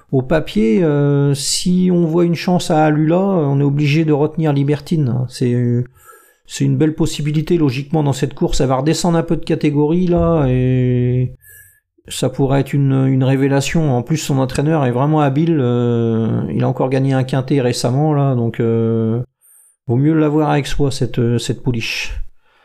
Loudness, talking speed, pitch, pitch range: -16 LUFS, 175 wpm, 145 Hz, 130-160 Hz